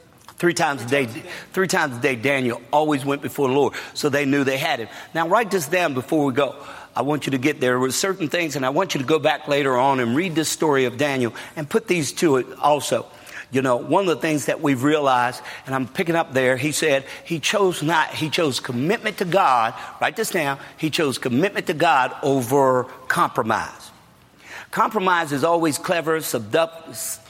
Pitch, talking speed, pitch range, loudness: 145 Hz, 215 wpm, 135-165 Hz, -21 LUFS